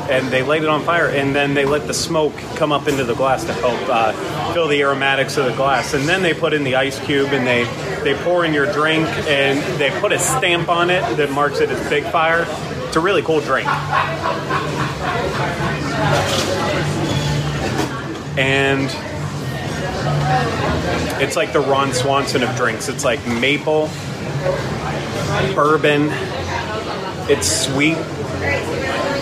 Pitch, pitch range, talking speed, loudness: 140 Hz, 135-155 Hz, 150 wpm, -18 LUFS